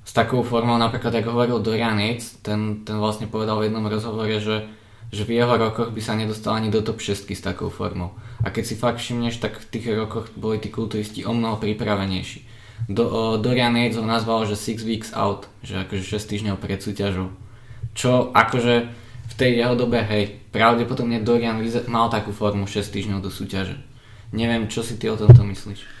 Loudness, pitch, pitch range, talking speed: -22 LUFS, 110 Hz, 105-115 Hz, 190 wpm